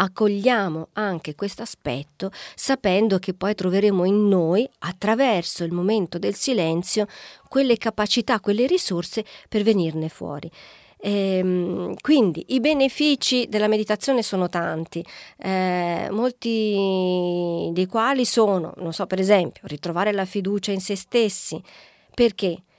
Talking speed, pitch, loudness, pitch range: 120 wpm, 200 Hz, -22 LUFS, 180-220 Hz